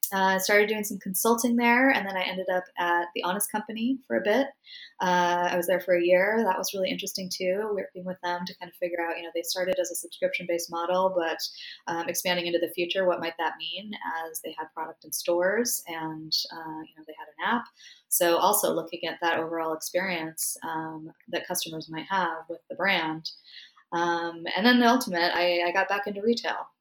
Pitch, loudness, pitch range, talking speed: 180 Hz, -27 LUFS, 170-190 Hz, 220 wpm